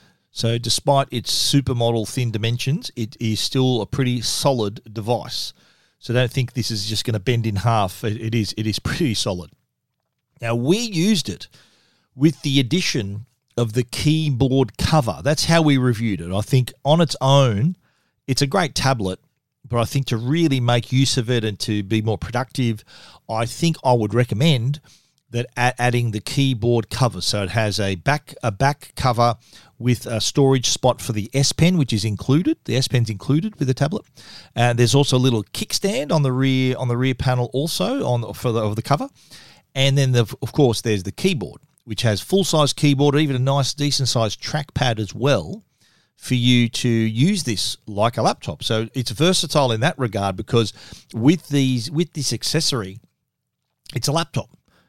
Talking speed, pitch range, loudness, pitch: 185 wpm, 115-140 Hz, -20 LUFS, 125 Hz